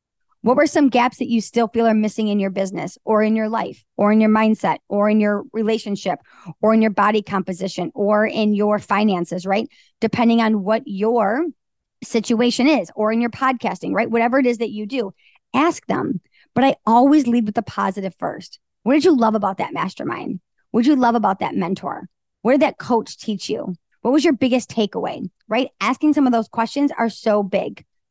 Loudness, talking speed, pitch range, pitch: -19 LUFS, 205 wpm, 210-245 Hz, 225 Hz